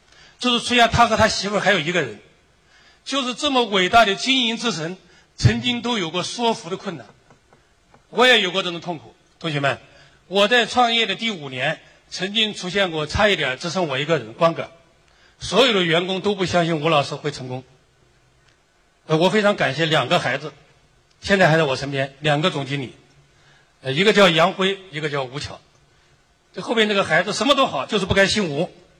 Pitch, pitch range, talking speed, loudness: 180 Hz, 150-210 Hz, 280 characters per minute, -19 LUFS